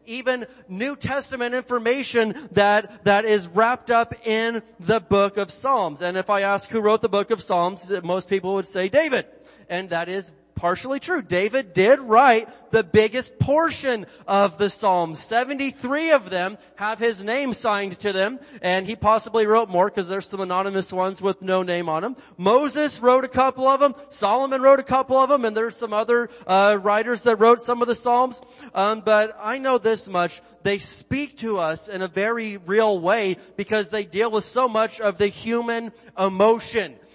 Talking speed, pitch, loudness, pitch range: 185 wpm, 220 Hz, -21 LUFS, 195-245 Hz